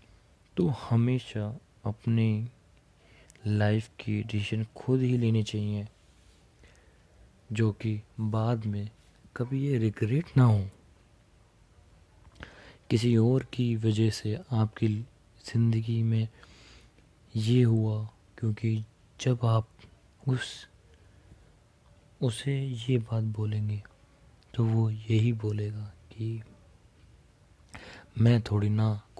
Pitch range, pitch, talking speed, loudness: 105-115 Hz, 110 Hz, 90 wpm, -29 LUFS